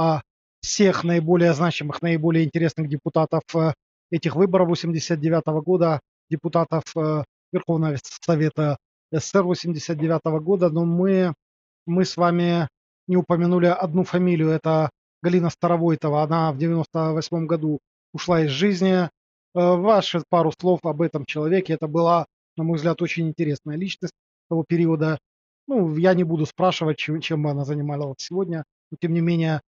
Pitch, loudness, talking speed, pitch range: 165 Hz, -22 LUFS, 140 wpm, 155-175 Hz